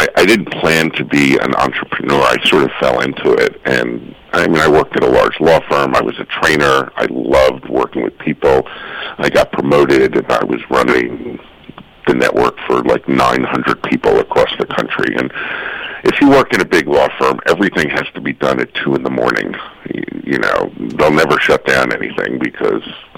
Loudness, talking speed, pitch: -13 LUFS, 195 wpm, 370 Hz